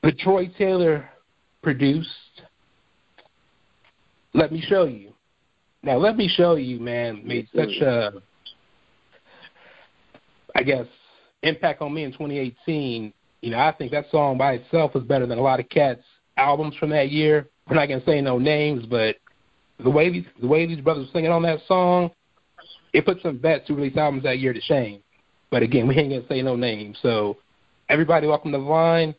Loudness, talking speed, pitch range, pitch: -22 LUFS, 185 wpm, 130-160 Hz, 145 Hz